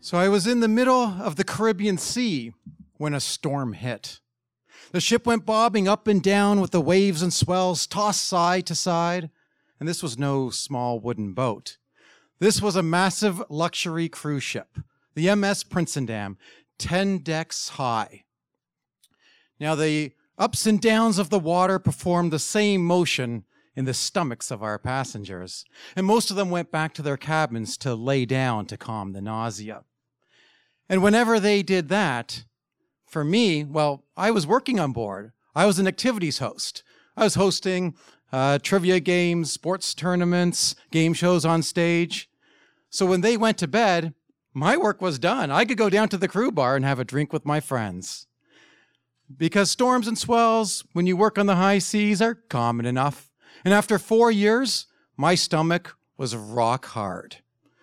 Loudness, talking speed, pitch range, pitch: -23 LUFS, 170 wpm, 140-205 Hz, 175 Hz